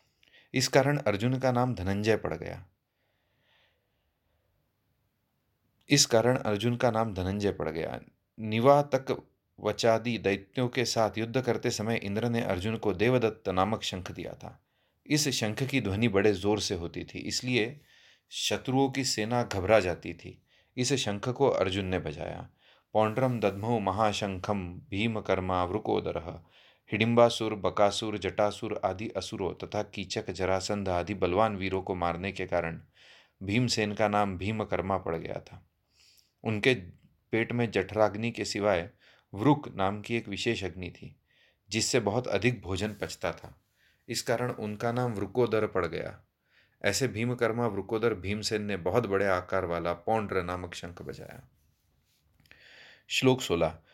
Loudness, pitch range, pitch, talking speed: -29 LUFS, 95-120 Hz, 105 Hz, 135 wpm